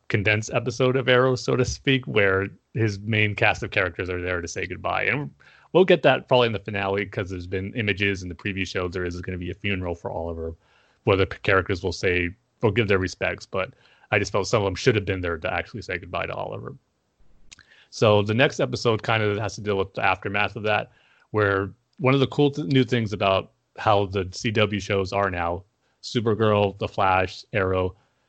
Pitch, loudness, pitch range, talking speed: 100 Hz, -24 LUFS, 95-120 Hz, 215 wpm